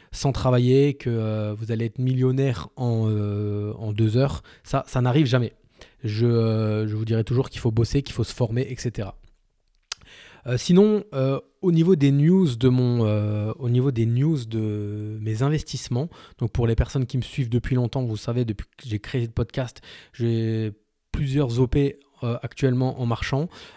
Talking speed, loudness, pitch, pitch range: 180 wpm, -24 LUFS, 120 Hz, 110-135 Hz